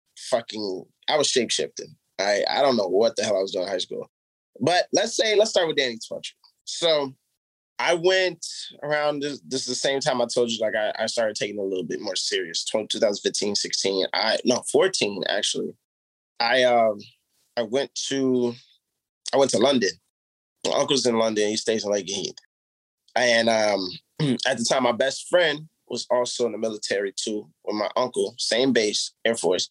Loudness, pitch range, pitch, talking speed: -23 LUFS, 110-160 Hz, 125 Hz, 190 wpm